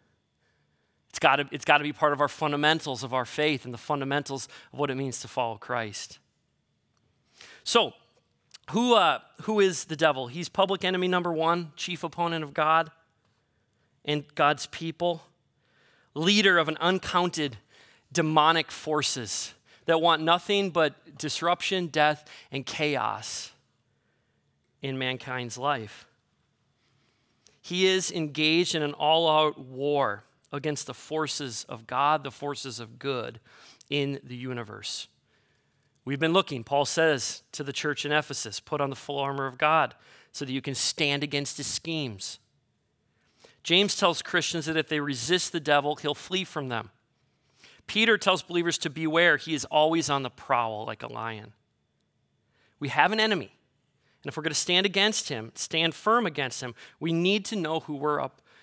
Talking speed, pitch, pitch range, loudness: 155 wpm, 150 Hz, 135-165 Hz, -26 LUFS